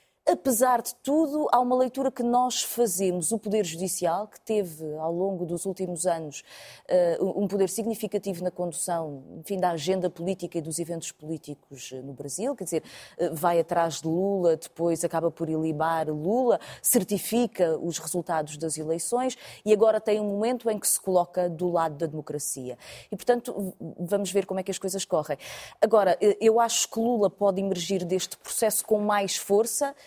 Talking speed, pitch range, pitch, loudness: 170 wpm, 165-215 Hz, 190 Hz, -26 LUFS